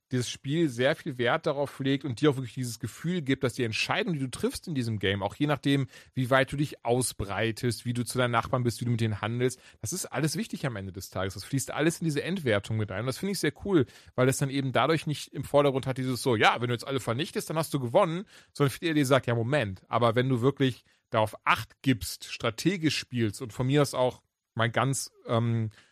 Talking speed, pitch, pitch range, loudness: 250 wpm, 130 Hz, 115-145 Hz, -28 LUFS